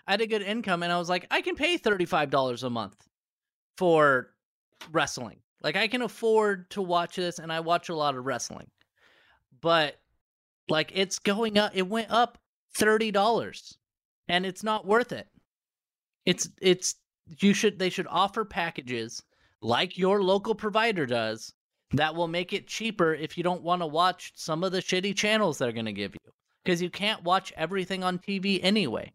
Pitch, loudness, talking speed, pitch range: 185 Hz, -27 LUFS, 180 wpm, 160-210 Hz